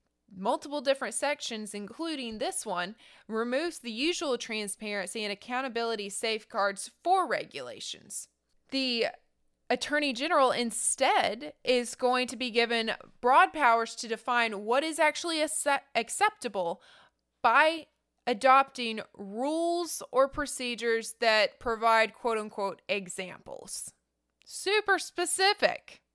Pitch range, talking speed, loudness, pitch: 220-295 Hz, 105 wpm, -29 LUFS, 245 Hz